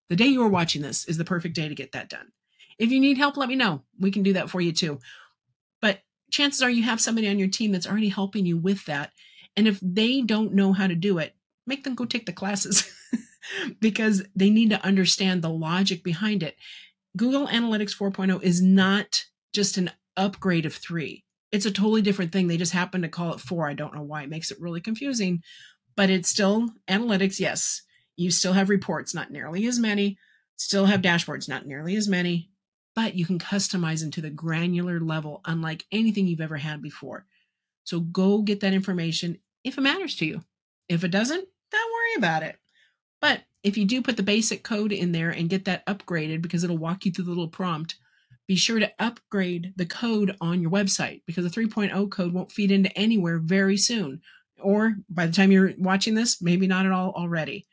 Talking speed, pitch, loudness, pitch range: 210 wpm, 190 Hz, -24 LUFS, 175-210 Hz